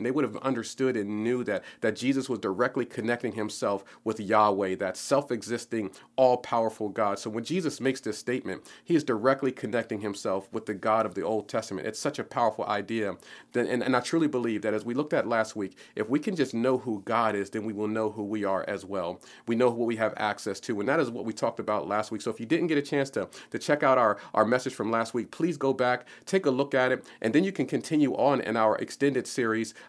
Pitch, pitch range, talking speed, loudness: 115 Hz, 110-130 Hz, 250 wpm, -28 LUFS